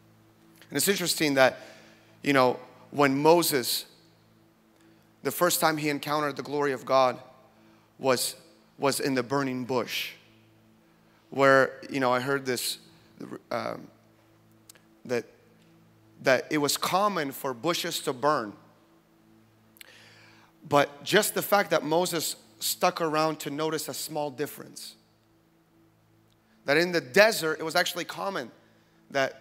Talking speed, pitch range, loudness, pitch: 125 wpm, 110-160 Hz, -26 LUFS, 140 Hz